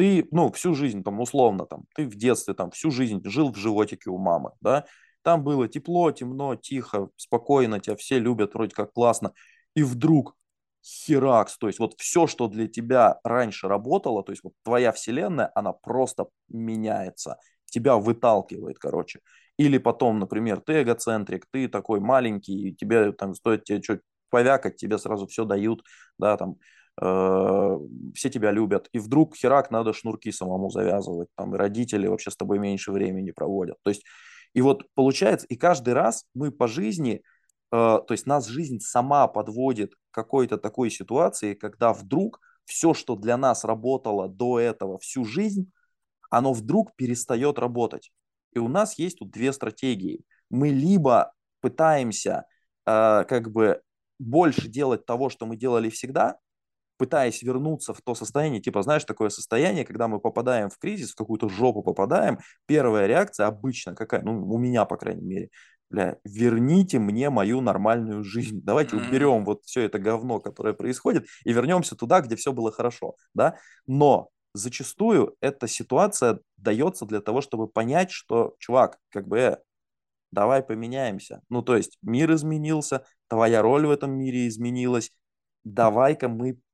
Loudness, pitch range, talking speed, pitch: -24 LUFS, 110-135 Hz, 160 wpm, 120 Hz